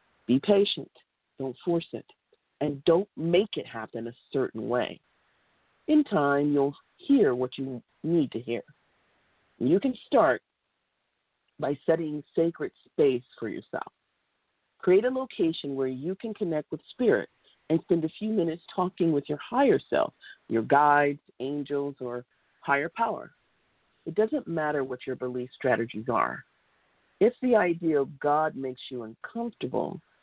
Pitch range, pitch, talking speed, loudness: 135-190 Hz, 150 Hz, 145 wpm, -28 LUFS